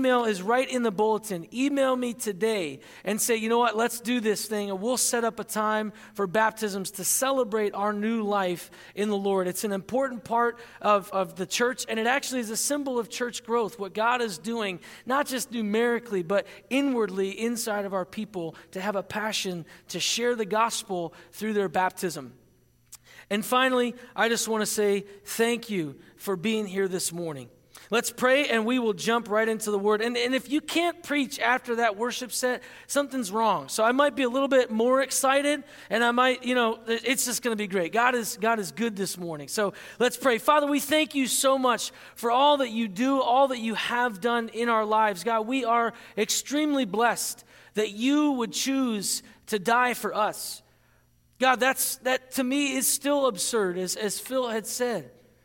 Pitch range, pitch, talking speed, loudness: 205-250 Hz, 230 Hz, 200 wpm, -26 LUFS